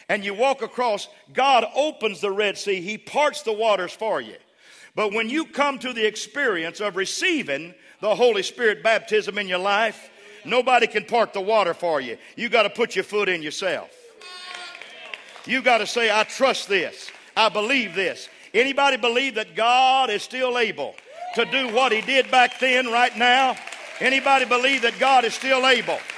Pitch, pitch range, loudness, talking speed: 240 Hz, 215-265 Hz, -21 LUFS, 180 wpm